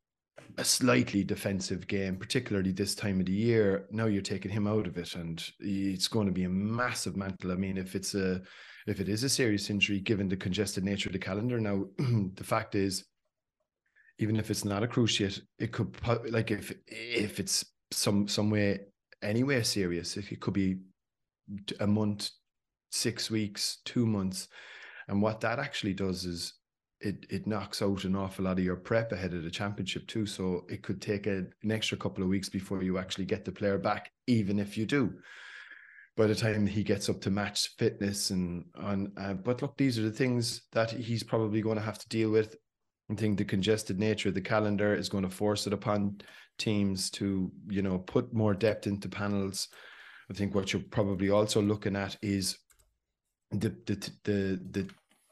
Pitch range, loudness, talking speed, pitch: 95-110 Hz, -32 LUFS, 195 wpm, 100 Hz